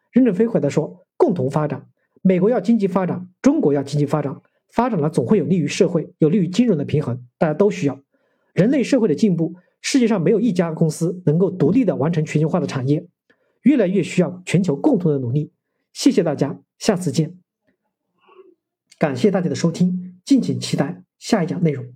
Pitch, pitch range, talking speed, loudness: 180 Hz, 150-215 Hz, 305 characters per minute, -19 LUFS